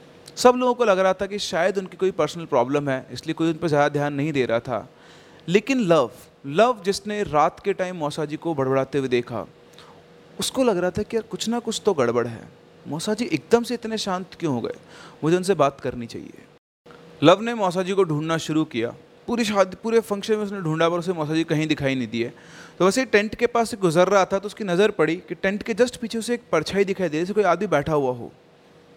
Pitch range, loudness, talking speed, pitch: 150-210 Hz, -22 LUFS, 240 wpm, 180 Hz